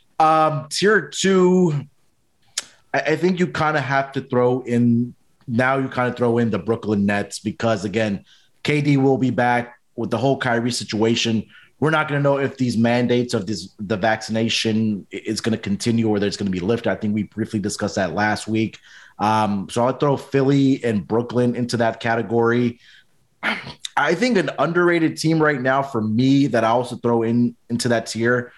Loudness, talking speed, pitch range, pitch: -20 LUFS, 185 wpm, 110-135 Hz, 120 Hz